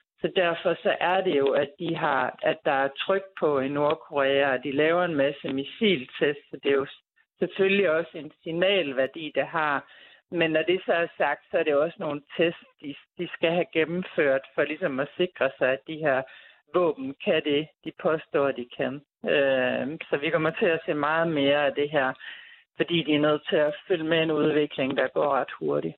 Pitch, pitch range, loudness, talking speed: 155 Hz, 140-170 Hz, -26 LUFS, 210 wpm